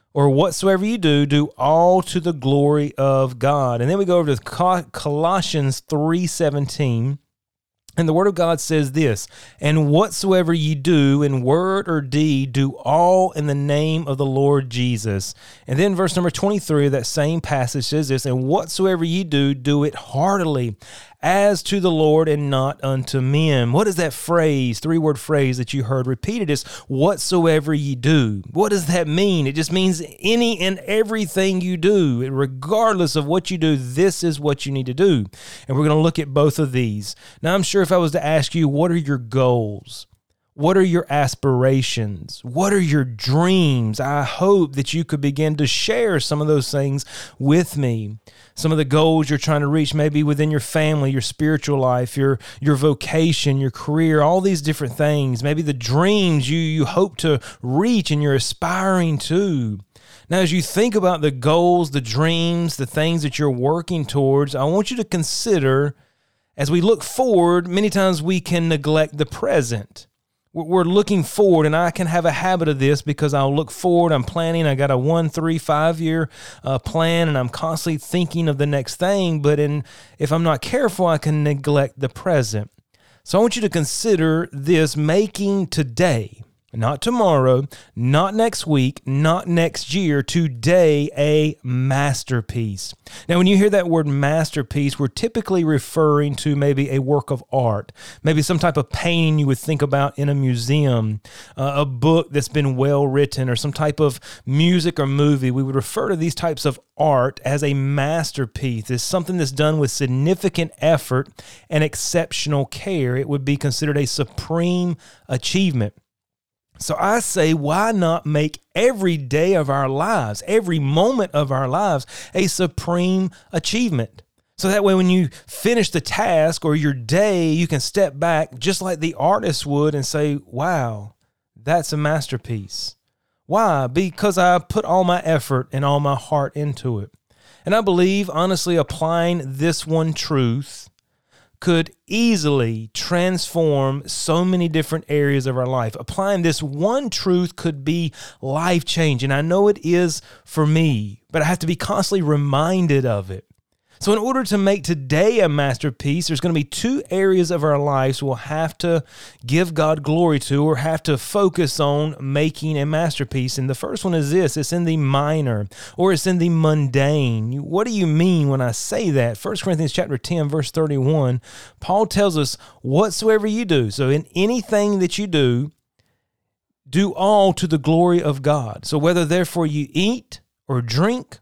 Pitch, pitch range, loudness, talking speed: 150 Hz, 135-175 Hz, -19 LUFS, 180 wpm